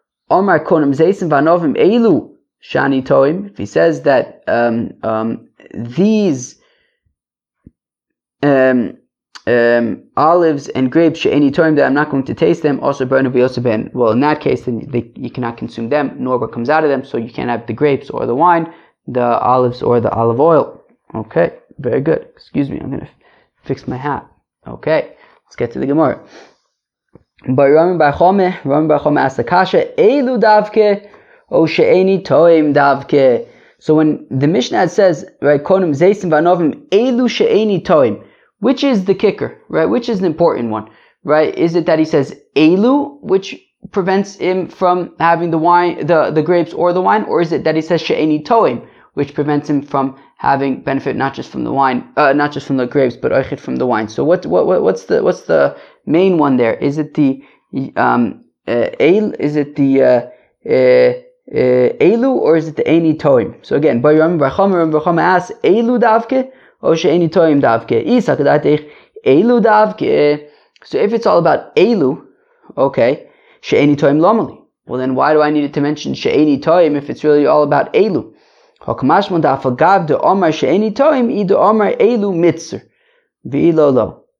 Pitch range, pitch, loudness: 140-195 Hz, 155 Hz, -13 LUFS